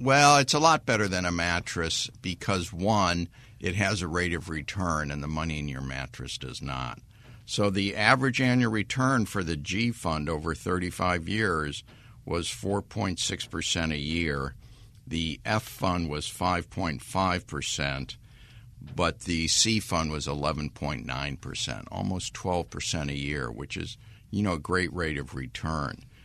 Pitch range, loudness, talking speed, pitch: 80-110 Hz, -28 LUFS, 145 wpm, 90 Hz